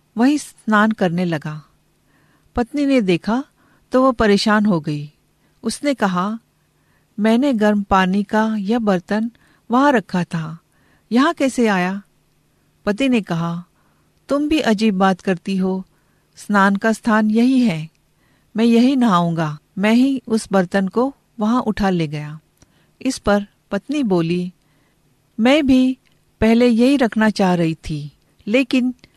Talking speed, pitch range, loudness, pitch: 135 wpm, 175-240 Hz, -18 LUFS, 210 Hz